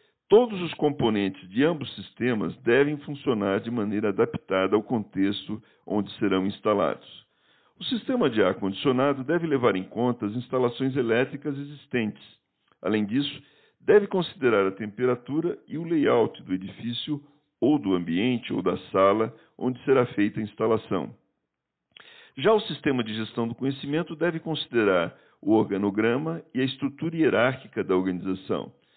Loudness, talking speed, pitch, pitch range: -26 LUFS, 140 wpm, 125 Hz, 105-150 Hz